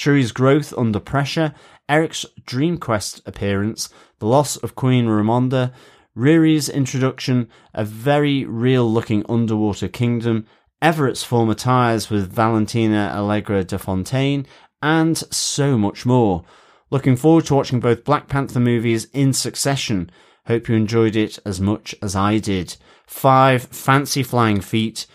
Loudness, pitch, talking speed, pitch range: -19 LUFS, 120 Hz, 130 wpm, 110-140 Hz